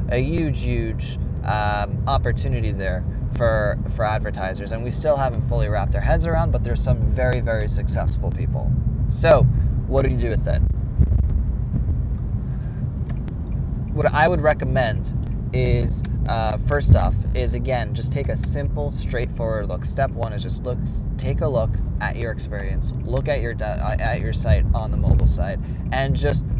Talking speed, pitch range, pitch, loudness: 160 wpm, 95-125 Hz, 110 Hz, -22 LUFS